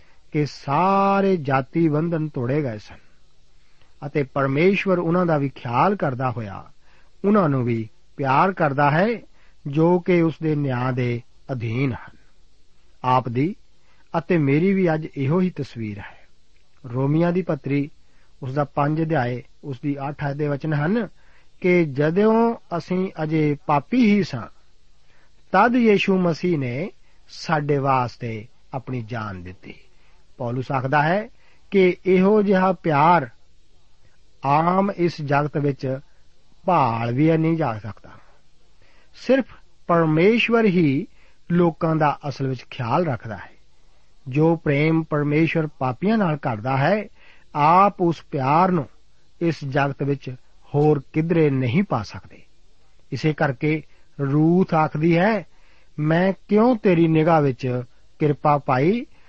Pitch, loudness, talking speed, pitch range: 150 Hz, -21 LUFS, 125 wpm, 130-175 Hz